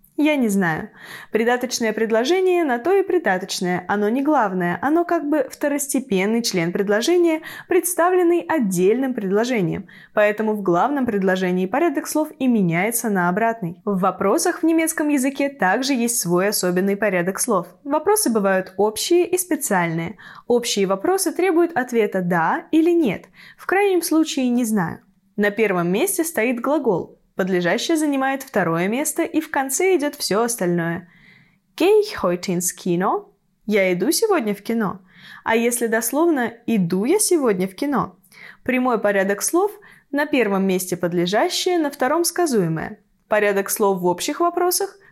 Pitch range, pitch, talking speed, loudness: 190-310 Hz, 225 Hz, 140 wpm, -20 LUFS